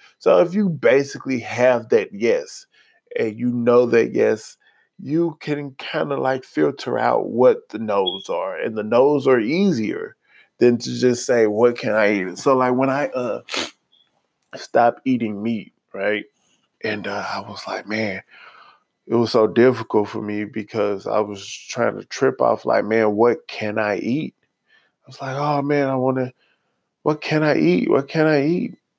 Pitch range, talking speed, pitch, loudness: 110-150 Hz, 180 wpm, 125 Hz, -20 LUFS